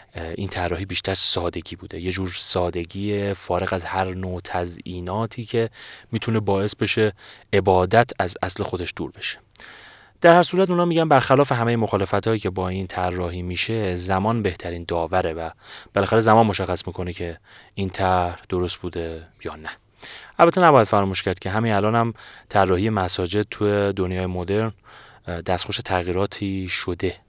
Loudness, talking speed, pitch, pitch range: -21 LUFS, 145 wpm, 95 Hz, 90-110 Hz